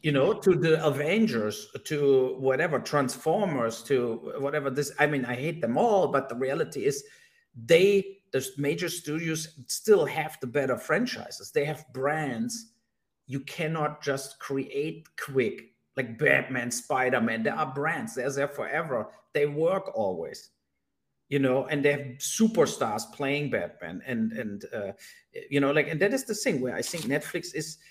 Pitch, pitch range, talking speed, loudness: 150 Hz, 140-195 Hz, 160 wpm, -28 LUFS